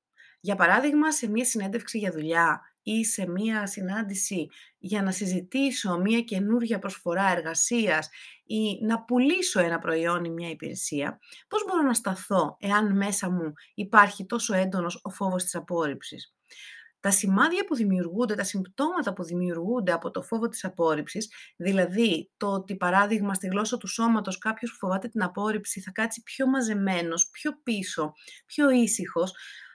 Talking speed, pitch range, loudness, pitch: 150 wpm, 185-230 Hz, -26 LUFS, 200 Hz